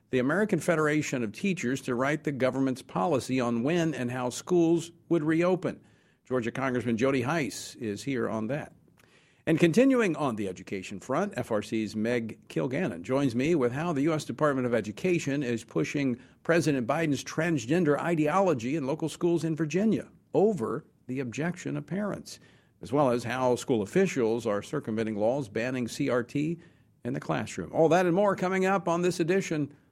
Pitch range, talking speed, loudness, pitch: 125-170 Hz, 165 wpm, -28 LUFS, 145 Hz